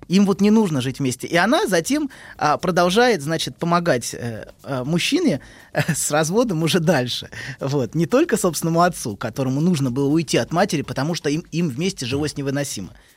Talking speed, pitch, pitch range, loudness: 180 wpm, 155 Hz, 135-180 Hz, -20 LUFS